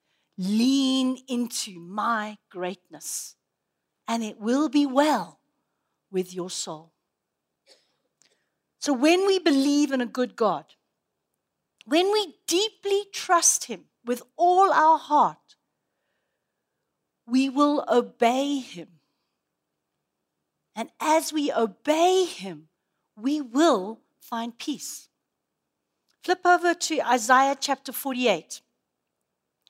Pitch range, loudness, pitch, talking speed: 220-310 Hz, -24 LUFS, 265 Hz, 95 wpm